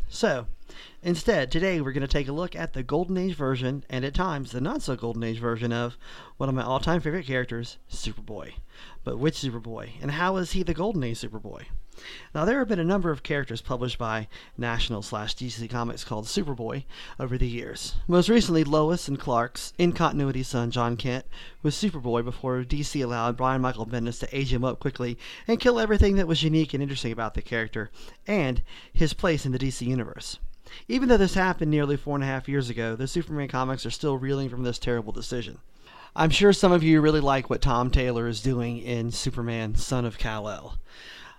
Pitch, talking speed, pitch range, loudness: 130 Hz, 205 wpm, 120-155 Hz, -27 LUFS